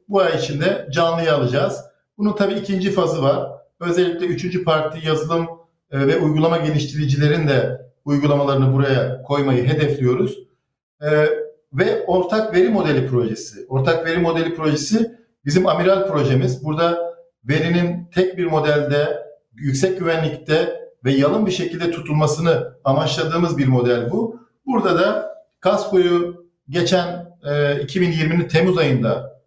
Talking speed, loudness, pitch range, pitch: 115 wpm, -19 LUFS, 145-180 Hz, 165 Hz